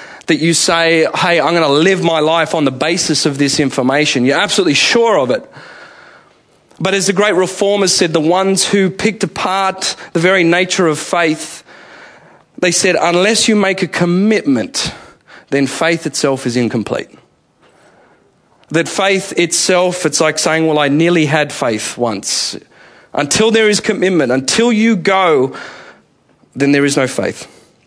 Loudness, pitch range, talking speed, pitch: -13 LUFS, 155-195 Hz, 155 wpm, 175 Hz